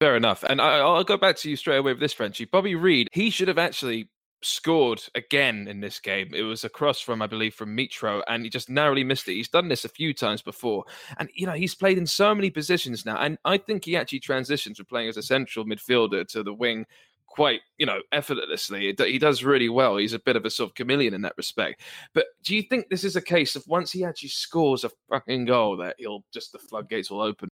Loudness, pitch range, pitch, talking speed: -24 LUFS, 115-175 Hz, 140 Hz, 250 wpm